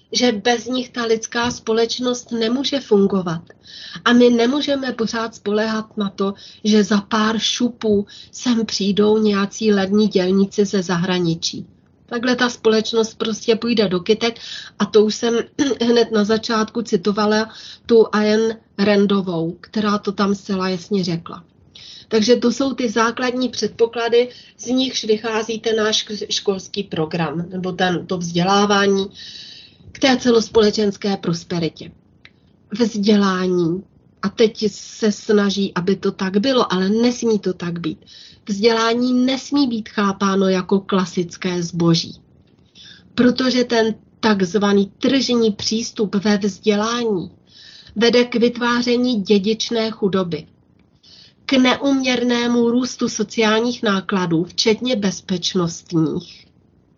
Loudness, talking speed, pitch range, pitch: -18 LUFS, 115 wpm, 195-235 Hz, 215 Hz